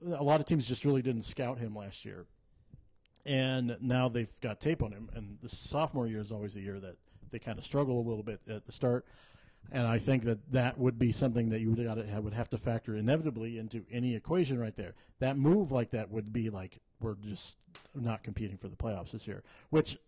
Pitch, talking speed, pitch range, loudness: 115 Hz, 220 wpm, 105-130 Hz, -34 LUFS